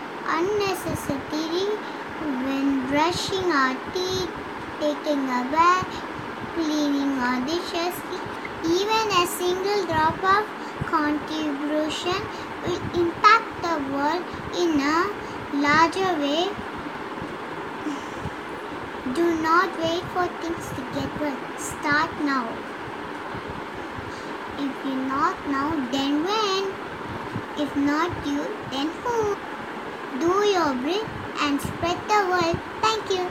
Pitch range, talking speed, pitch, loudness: 295-370 Hz, 100 wpm, 330 Hz, -25 LUFS